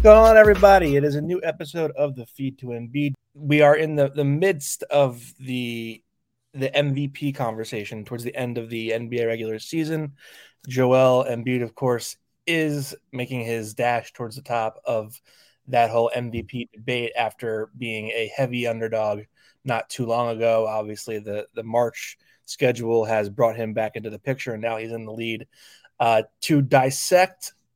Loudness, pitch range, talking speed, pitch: -22 LUFS, 115-140 Hz, 170 wpm, 120 Hz